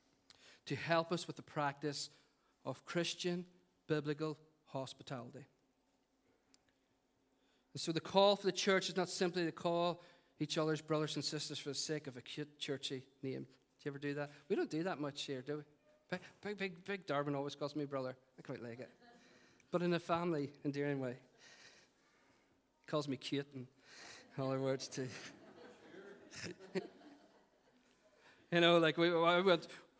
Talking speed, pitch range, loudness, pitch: 160 wpm, 140-175 Hz, -39 LUFS, 150 Hz